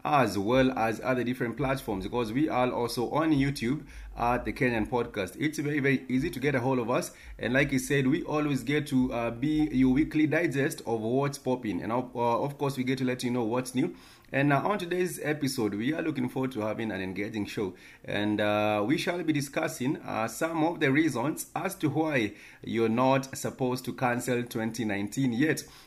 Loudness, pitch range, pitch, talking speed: -29 LUFS, 120-145 Hz, 130 Hz, 210 wpm